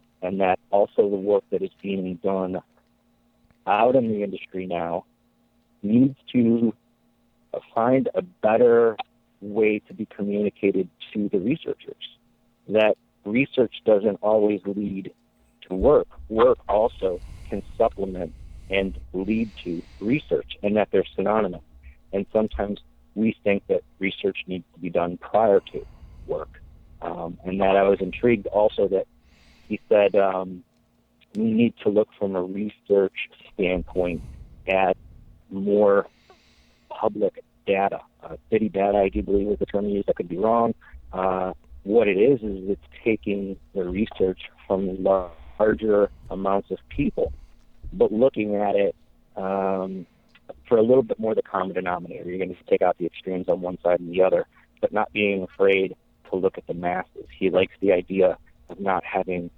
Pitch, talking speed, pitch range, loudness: 100 Hz, 150 wpm, 90-110 Hz, -24 LUFS